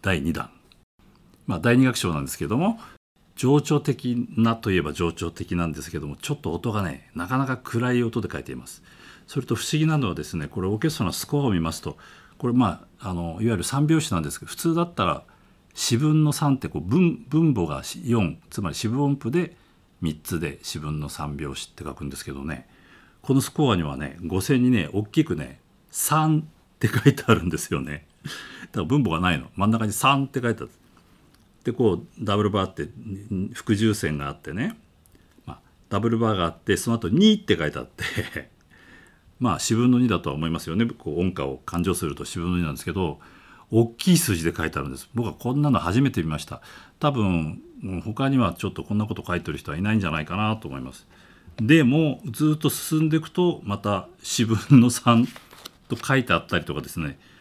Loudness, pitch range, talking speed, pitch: -24 LUFS, 85-130 Hz, 400 characters per minute, 110 Hz